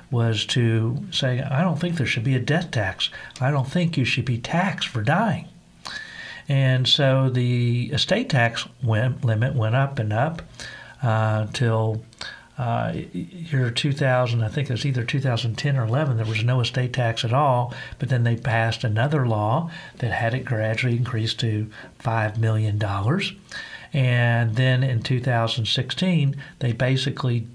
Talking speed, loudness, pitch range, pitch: 155 wpm, -23 LUFS, 115-140 Hz, 125 Hz